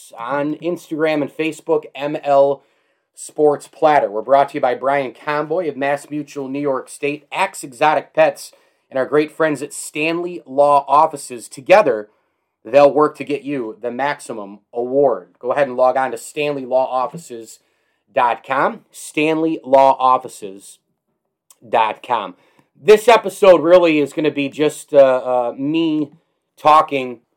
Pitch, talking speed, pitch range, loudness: 145 Hz, 130 wpm, 135-155 Hz, -17 LUFS